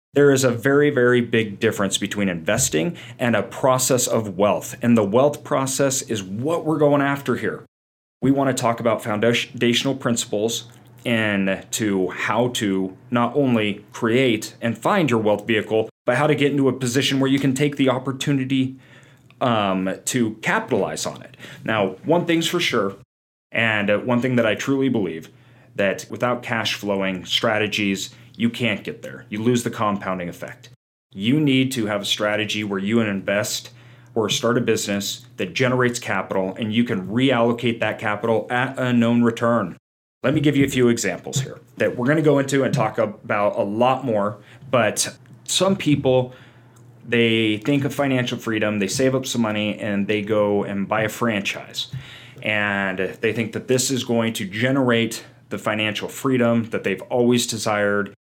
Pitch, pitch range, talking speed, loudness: 120 Hz, 105-130 Hz, 175 wpm, -21 LUFS